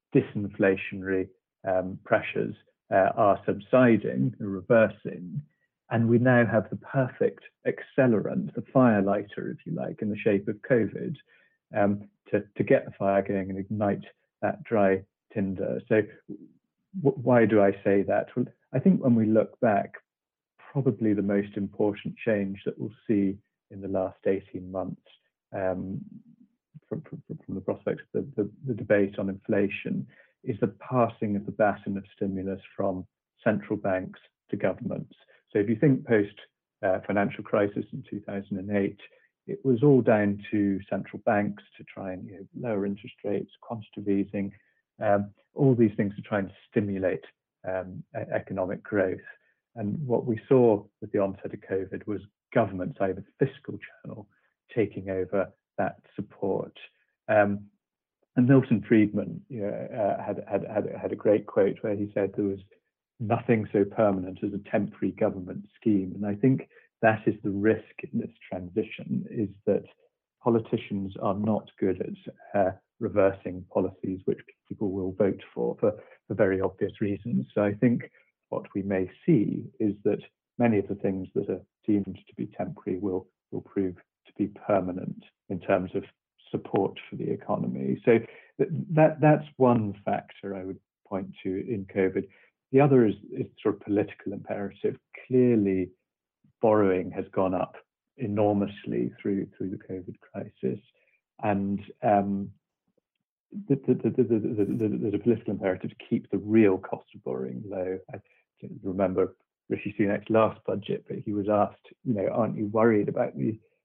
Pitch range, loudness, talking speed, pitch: 95-115 Hz, -28 LUFS, 160 wpm, 100 Hz